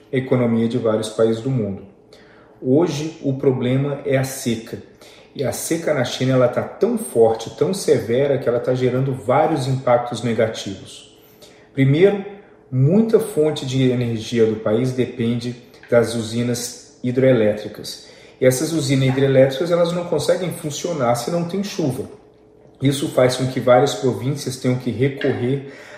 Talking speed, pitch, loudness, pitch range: 145 wpm, 130 Hz, -19 LUFS, 120-145 Hz